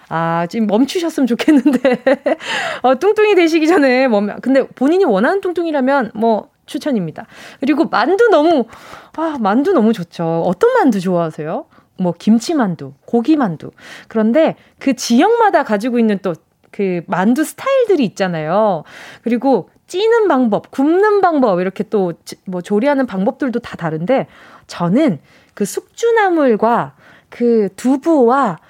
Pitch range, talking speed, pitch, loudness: 200-315 Hz, 290 characters per minute, 255 Hz, -15 LUFS